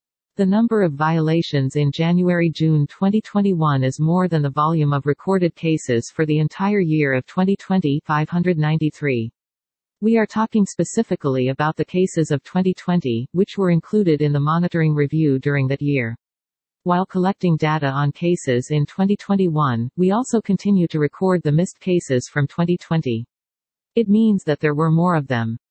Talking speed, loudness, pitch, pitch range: 155 wpm, -19 LUFS, 160 Hz, 145-185 Hz